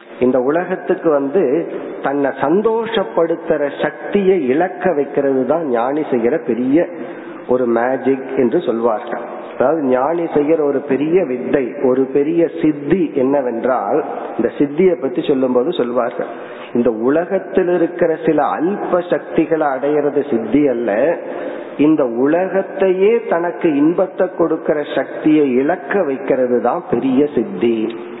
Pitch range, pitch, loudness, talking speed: 130-180 Hz, 150 Hz, -16 LUFS, 110 wpm